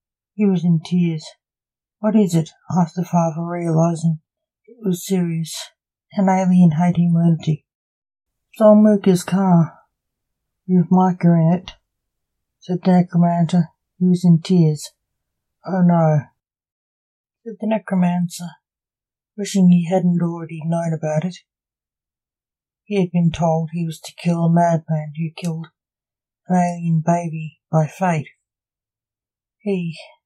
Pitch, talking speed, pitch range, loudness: 170 Hz, 120 wpm, 160-185 Hz, -18 LUFS